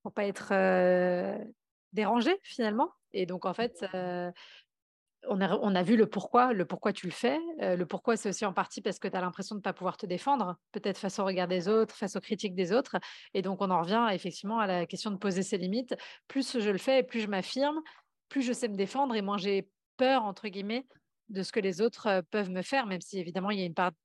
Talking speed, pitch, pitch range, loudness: 245 wpm, 205 Hz, 185-230 Hz, -31 LUFS